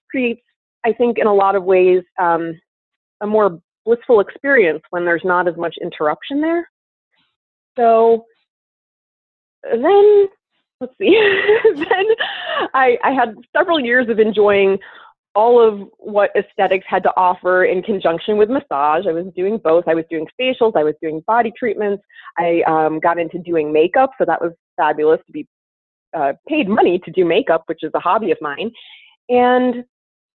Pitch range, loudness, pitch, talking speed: 170-265 Hz, -16 LUFS, 210 Hz, 160 wpm